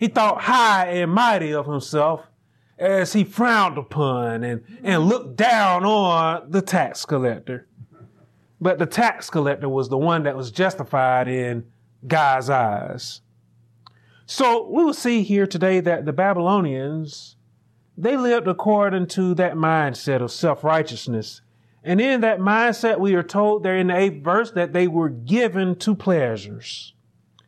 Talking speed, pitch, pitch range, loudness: 145 wpm, 170 Hz, 130-195 Hz, -20 LUFS